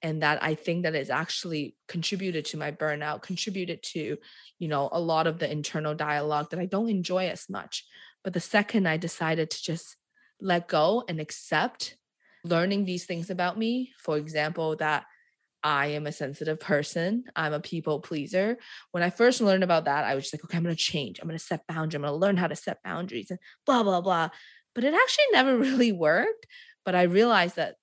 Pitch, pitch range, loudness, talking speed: 170 Hz, 155-190 Hz, -27 LUFS, 210 wpm